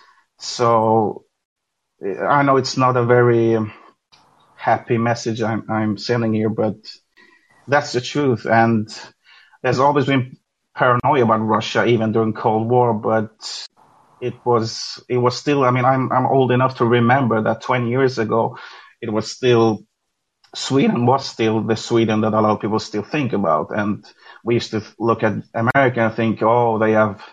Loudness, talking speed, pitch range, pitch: -18 LUFS, 160 wpm, 110-125 Hz, 115 Hz